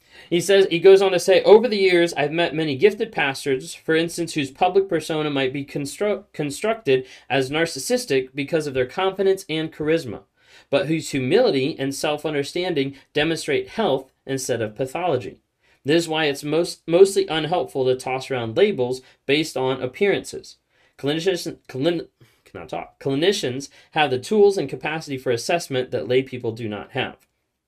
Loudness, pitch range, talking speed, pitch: -21 LUFS, 135-175 Hz, 160 wpm, 150 Hz